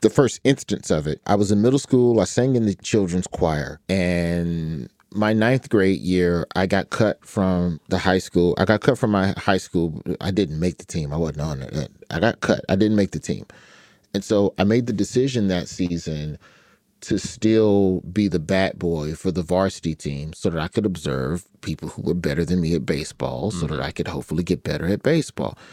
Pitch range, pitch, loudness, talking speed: 85-105 Hz, 90 Hz, -22 LUFS, 215 wpm